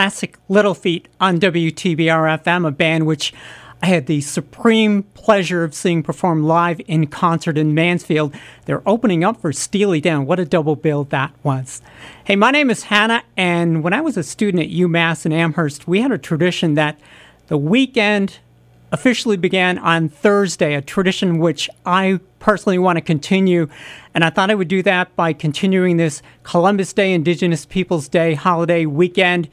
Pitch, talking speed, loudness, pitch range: 175 Hz, 170 wpm, -17 LUFS, 160-195 Hz